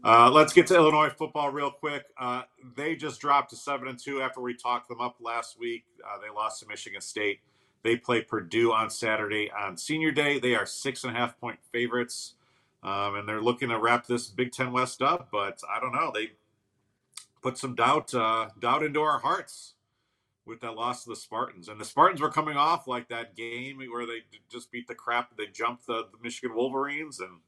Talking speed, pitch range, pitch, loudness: 210 wpm, 115-140 Hz, 120 Hz, -28 LUFS